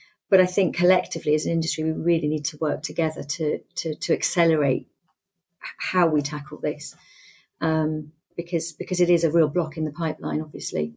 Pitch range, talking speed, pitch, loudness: 150-170 Hz, 180 wpm, 160 Hz, -24 LUFS